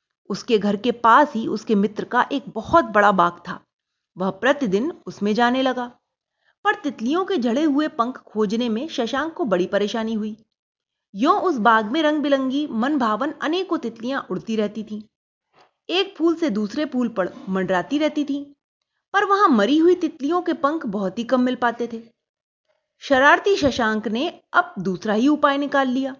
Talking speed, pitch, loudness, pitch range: 170 wpm, 250 Hz, -21 LUFS, 220-300 Hz